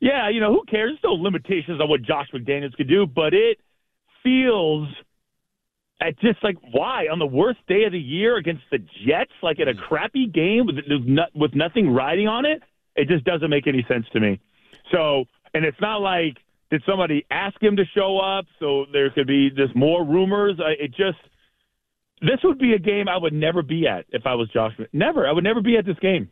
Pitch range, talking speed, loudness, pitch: 145-205 Hz, 215 wpm, -21 LUFS, 170 Hz